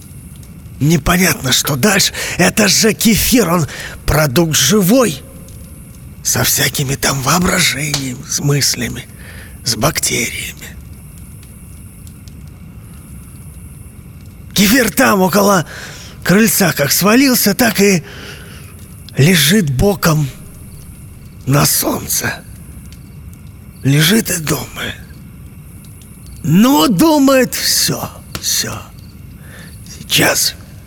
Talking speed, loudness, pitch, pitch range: 70 wpm, -12 LUFS, 160 Hz, 130-205 Hz